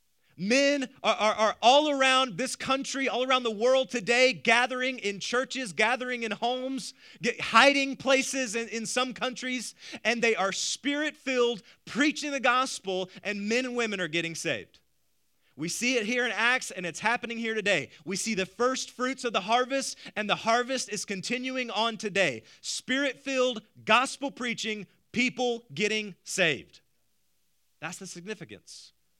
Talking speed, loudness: 160 wpm, -27 LUFS